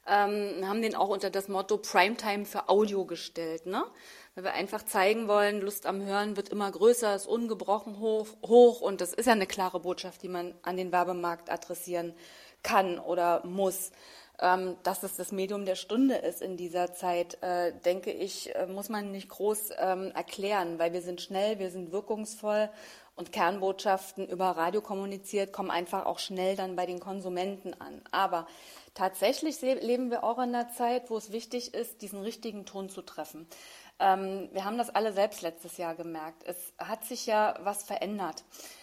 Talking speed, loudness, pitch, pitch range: 175 wpm, -31 LUFS, 195 Hz, 180-210 Hz